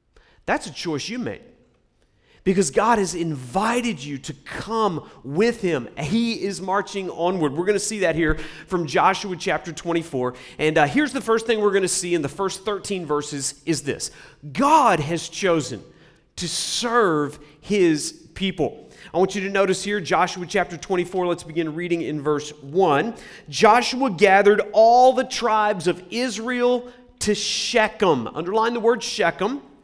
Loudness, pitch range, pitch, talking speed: -21 LUFS, 160-220 Hz, 190 Hz, 160 wpm